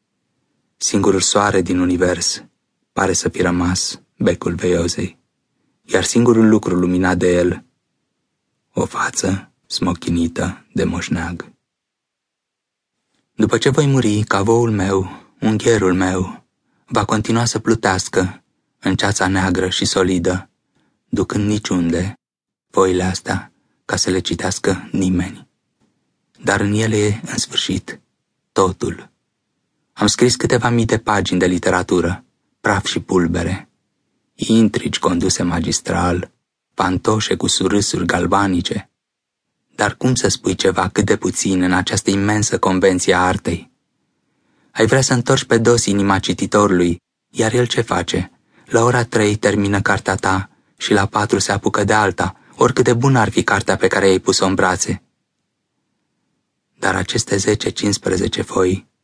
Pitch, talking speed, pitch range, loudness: 100 Hz, 130 wpm, 95-110 Hz, -17 LUFS